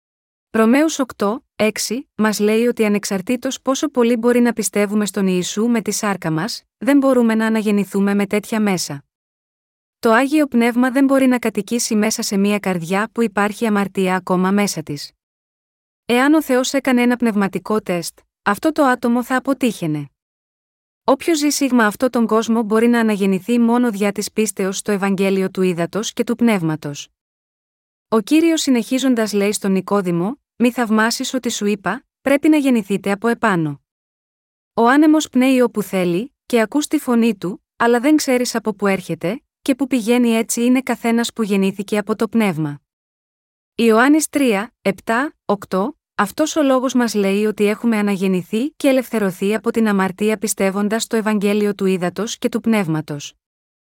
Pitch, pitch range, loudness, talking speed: 220 Hz, 200-245 Hz, -18 LUFS, 160 wpm